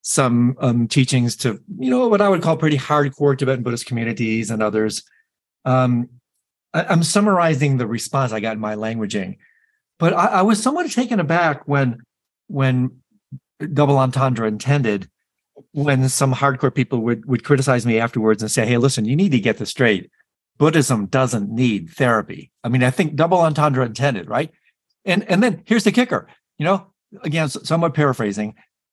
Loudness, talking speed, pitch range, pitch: -19 LUFS, 170 wpm, 120-170 Hz, 135 Hz